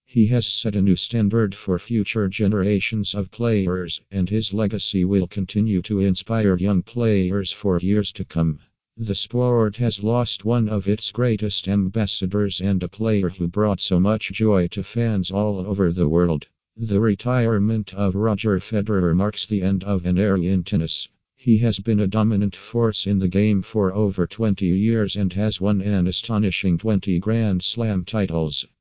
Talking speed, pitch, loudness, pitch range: 170 wpm, 100 Hz, -21 LUFS, 95-110 Hz